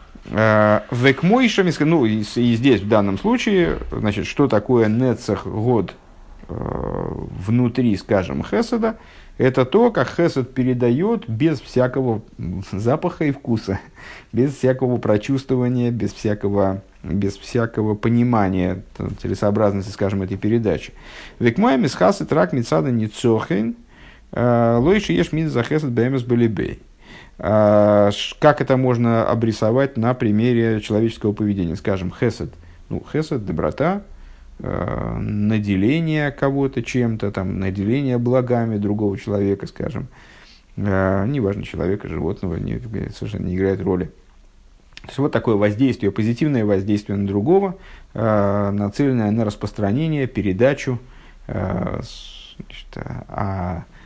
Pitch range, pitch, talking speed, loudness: 100-130 Hz, 115 Hz, 110 wpm, -20 LUFS